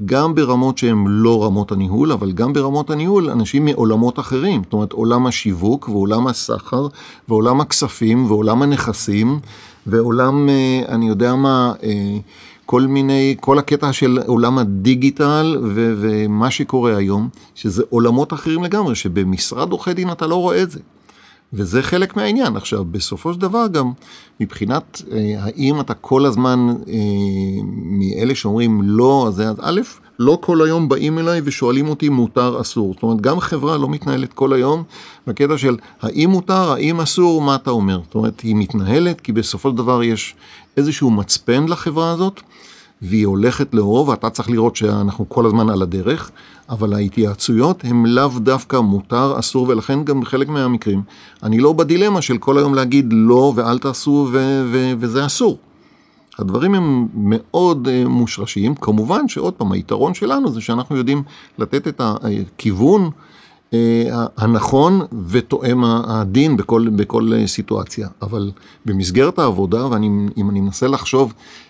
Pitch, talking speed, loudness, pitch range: 125 Hz, 145 wpm, -16 LUFS, 110-140 Hz